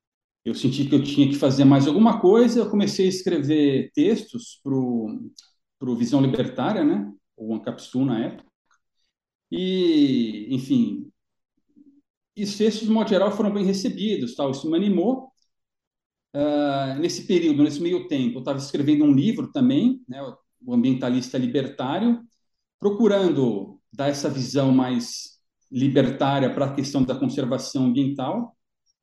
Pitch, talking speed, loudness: 170 Hz, 140 wpm, -22 LUFS